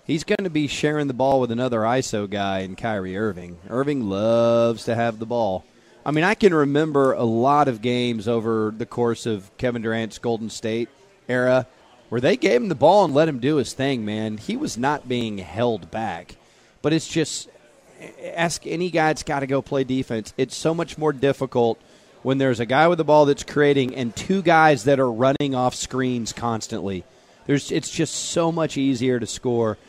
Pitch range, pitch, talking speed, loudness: 115-145 Hz, 130 Hz, 200 wpm, -22 LUFS